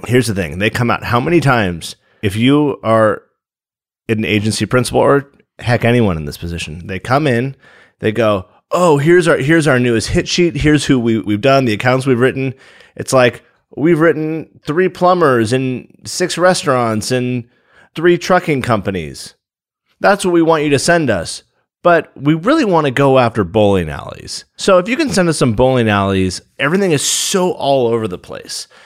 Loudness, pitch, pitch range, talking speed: -14 LUFS, 130 Hz, 110-160 Hz, 185 wpm